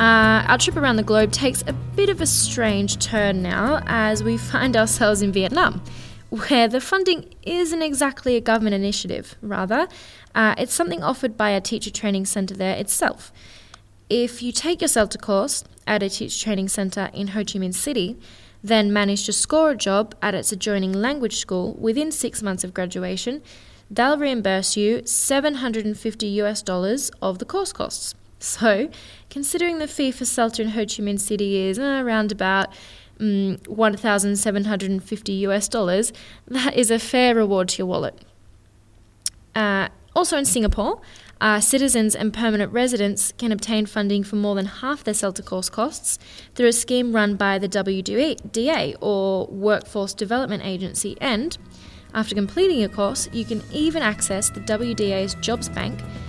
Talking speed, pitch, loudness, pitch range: 165 wpm, 210 Hz, -21 LUFS, 195-240 Hz